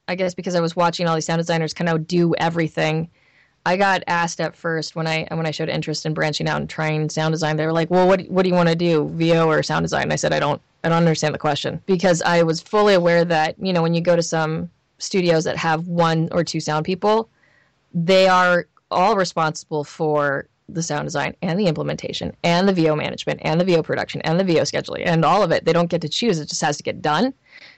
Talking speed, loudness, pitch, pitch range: 250 wpm, -20 LUFS, 165 Hz, 155-175 Hz